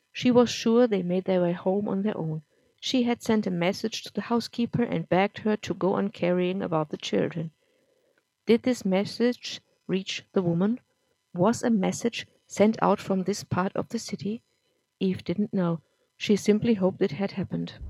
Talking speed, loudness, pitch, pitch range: 185 wpm, -27 LUFS, 195 Hz, 185-225 Hz